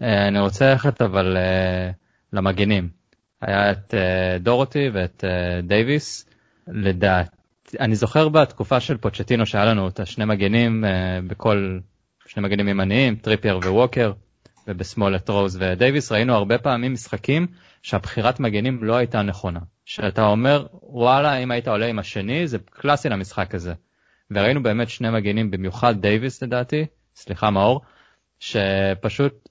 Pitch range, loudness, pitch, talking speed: 95-125 Hz, -21 LUFS, 105 Hz, 135 wpm